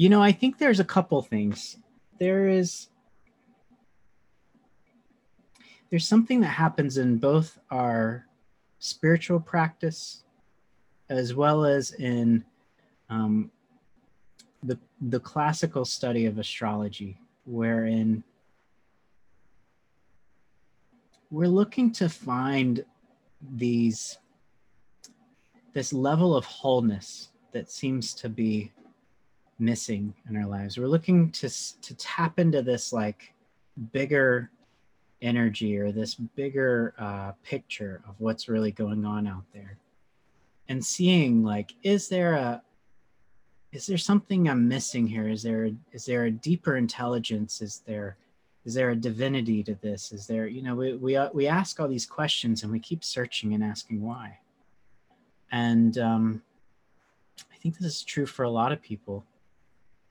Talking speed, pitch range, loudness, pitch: 125 wpm, 110-155 Hz, -27 LUFS, 125 Hz